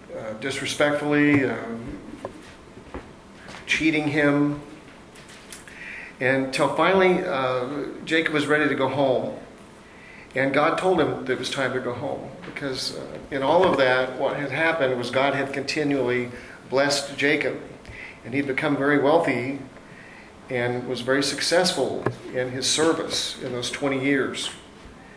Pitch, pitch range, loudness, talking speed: 140 Hz, 130-145 Hz, -23 LUFS, 135 wpm